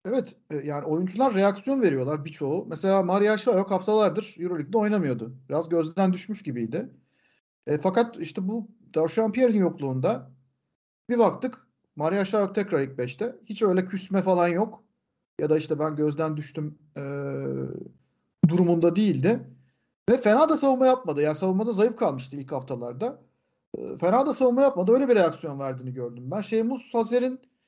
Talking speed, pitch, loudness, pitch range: 145 wpm, 185 Hz, -25 LUFS, 150-220 Hz